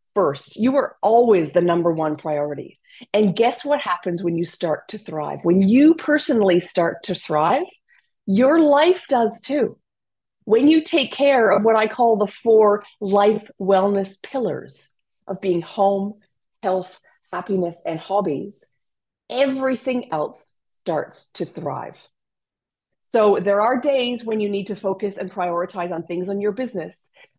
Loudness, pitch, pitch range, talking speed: -20 LUFS, 205 Hz, 180-245 Hz, 150 wpm